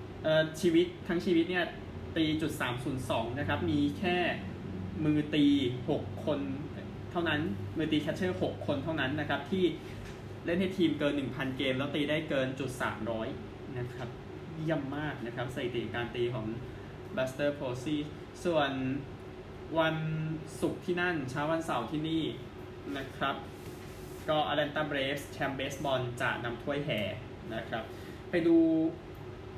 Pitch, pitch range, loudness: 145 Hz, 125-160 Hz, -33 LUFS